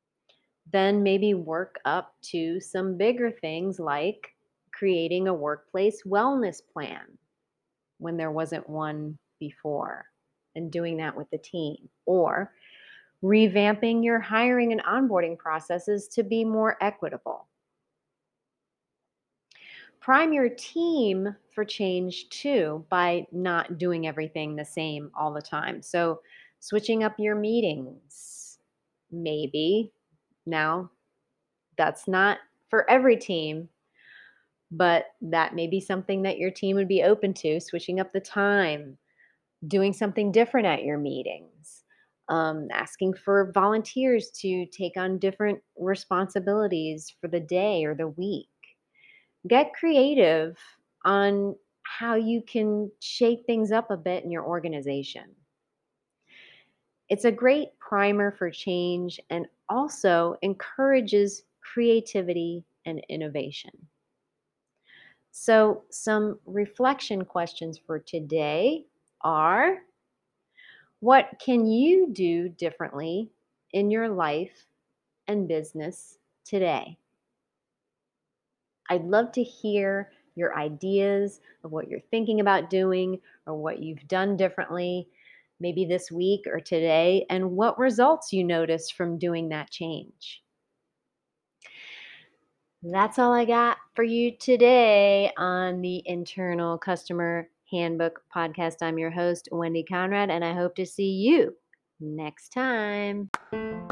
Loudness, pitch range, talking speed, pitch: -26 LUFS, 165-215 Hz, 115 wpm, 185 Hz